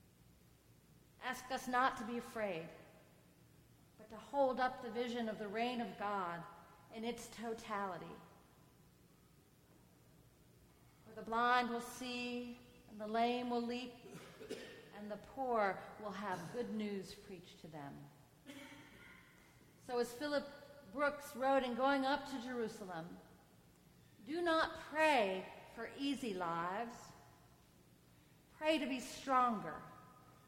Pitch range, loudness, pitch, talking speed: 190-255 Hz, -40 LUFS, 235 Hz, 120 wpm